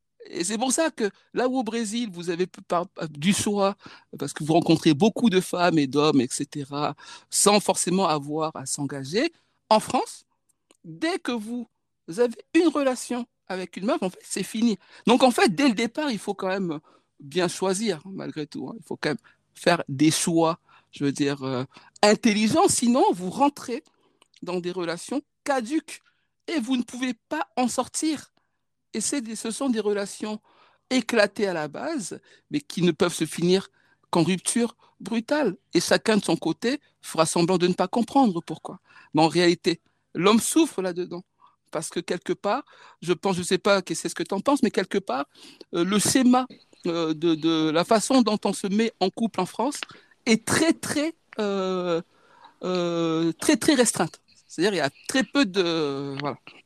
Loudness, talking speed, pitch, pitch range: -24 LUFS, 185 wpm, 200 Hz, 170-245 Hz